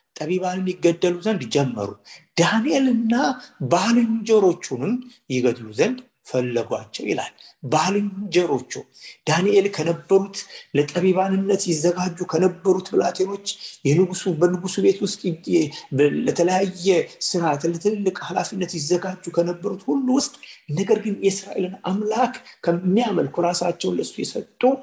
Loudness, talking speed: -22 LUFS, 90 wpm